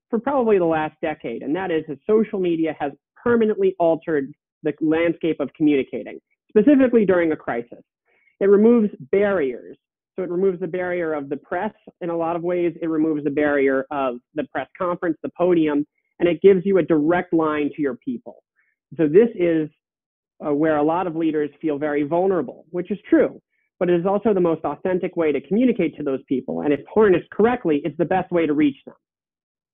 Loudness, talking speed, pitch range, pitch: -21 LUFS, 195 wpm, 150-190 Hz, 165 Hz